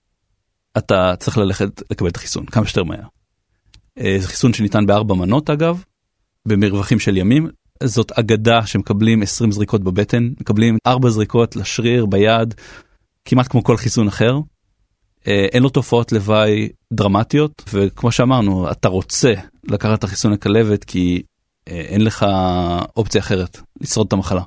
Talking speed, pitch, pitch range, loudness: 135 wpm, 105 Hz, 100-115 Hz, -17 LUFS